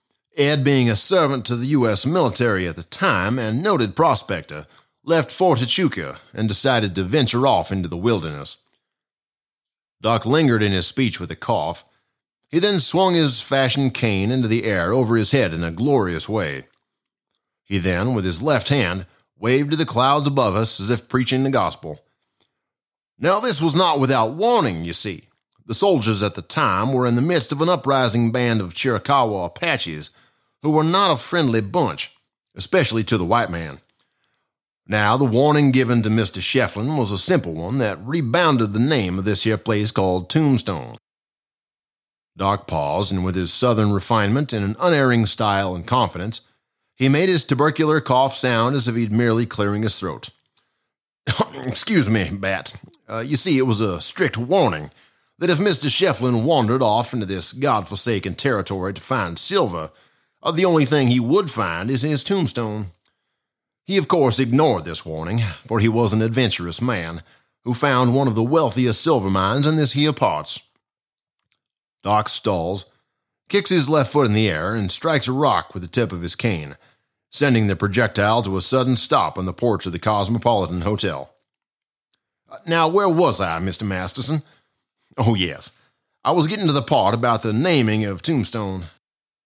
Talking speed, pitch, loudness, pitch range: 175 wpm, 120 Hz, -19 LUFS, 100-140 Hz